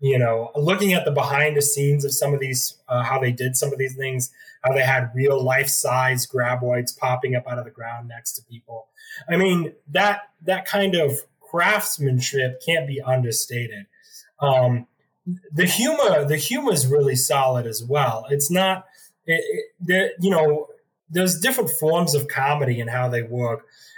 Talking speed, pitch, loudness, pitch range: 180 wpm, 140 Hz, -21 LUFS, 125-180 Hz